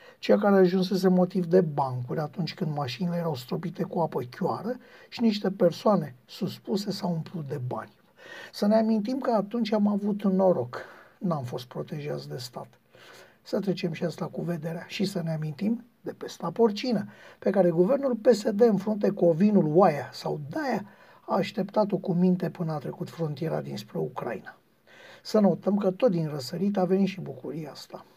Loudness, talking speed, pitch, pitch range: -27 LUFS, 175 wpm, 185 Hz, 170-210 Hz